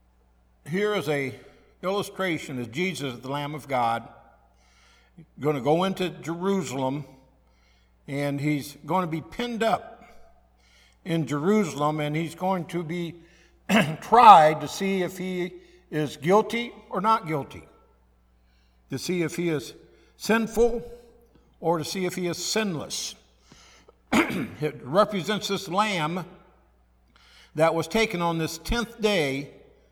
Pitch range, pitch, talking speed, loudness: 135-190 Hz, 165 Hz, 125 wpm, -25 LUFS